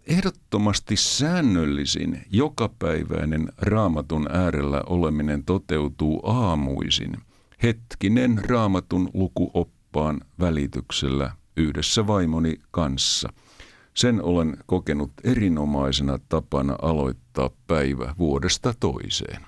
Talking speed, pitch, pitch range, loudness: 75 wpm, 80 Hz, 70-100 Hz, -24 LUFS